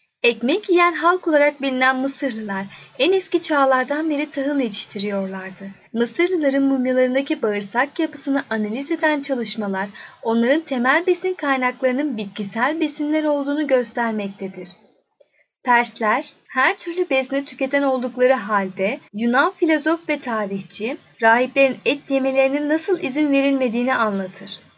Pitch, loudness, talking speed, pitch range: 265 Hz, -20 LUFS, 110 wpm, 225-295 Hz